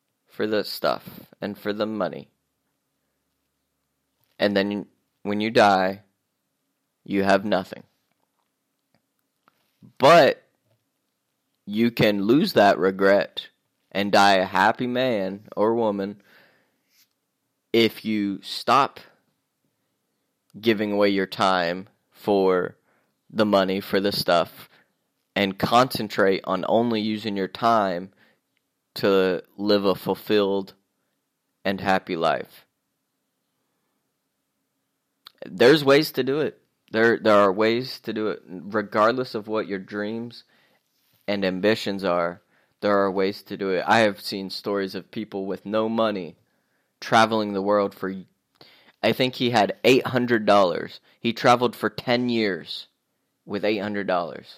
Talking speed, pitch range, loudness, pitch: 115 wpm, 95-110 Hz, -22 LUFS, 100 Hz